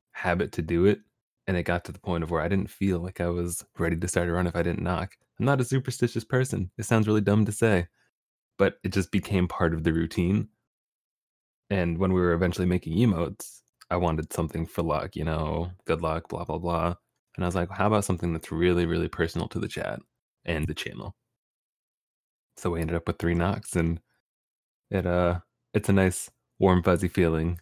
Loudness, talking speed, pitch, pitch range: -27 LUFS, 215 wpm, 90 Hz, 85-100 Hz